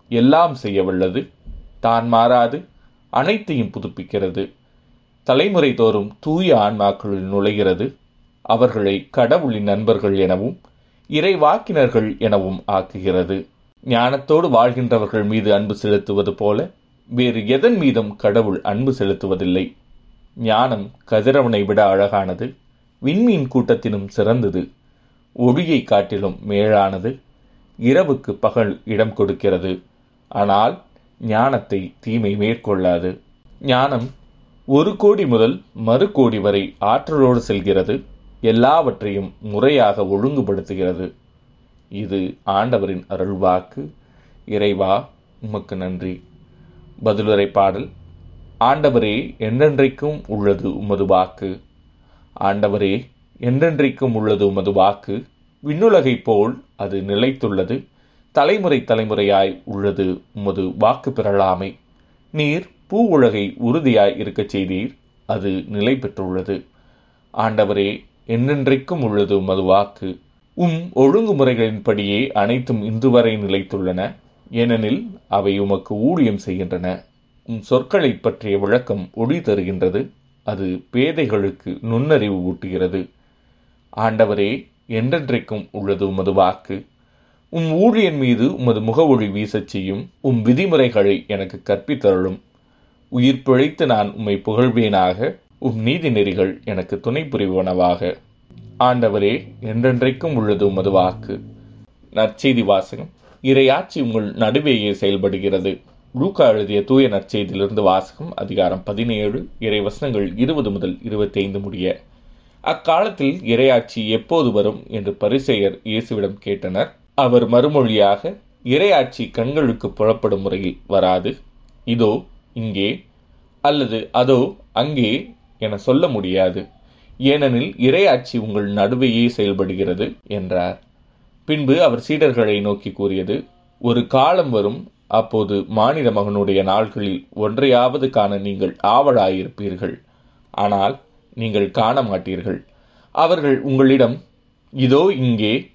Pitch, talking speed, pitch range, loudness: 105 Hz, 90 wpm, 100-125 Hz, -18 LUFS